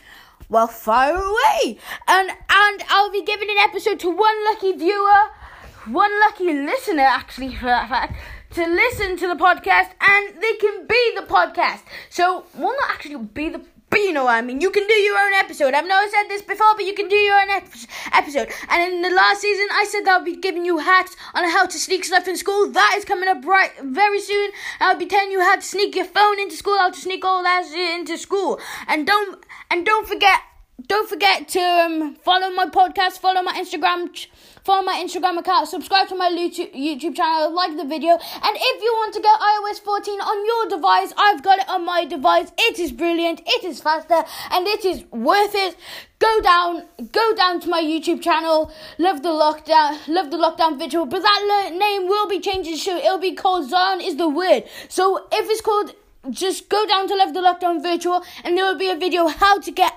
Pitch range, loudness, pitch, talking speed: 340-405 Hz, -18 LUFS, 370 Hz, 215 wpm